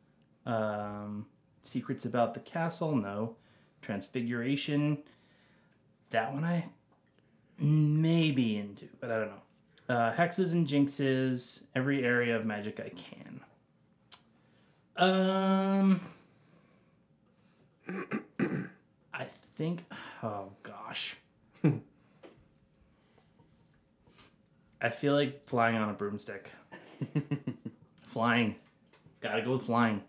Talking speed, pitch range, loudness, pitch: 90 wpm, 115-155 Hz, -32 LUFS, 130 Hz